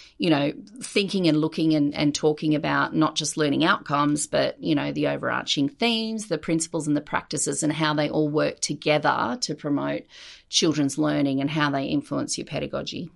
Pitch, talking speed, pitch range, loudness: 155 Hz, 185 wpm, 145-165 Hz, -24 LUFS